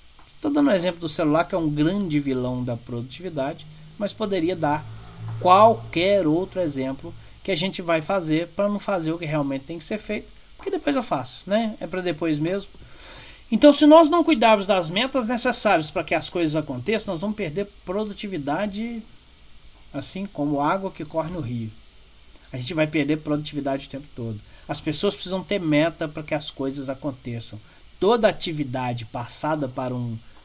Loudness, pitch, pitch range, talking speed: -23 LUFS, 160 Hz, 135-200 Hz, 180 wpm